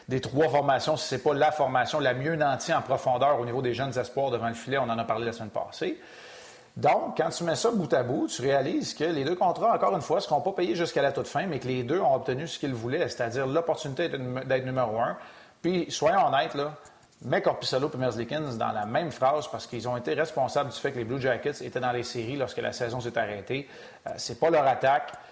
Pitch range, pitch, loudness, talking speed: 125-150 Hz, 130 Hz, -28 LUFS, 245 wpm